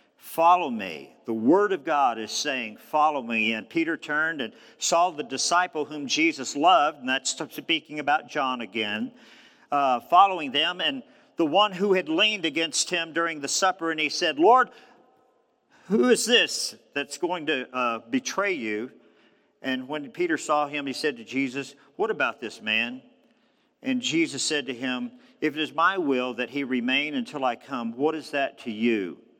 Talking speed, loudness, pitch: 180 wpm, -25 LUFS, 165 Hz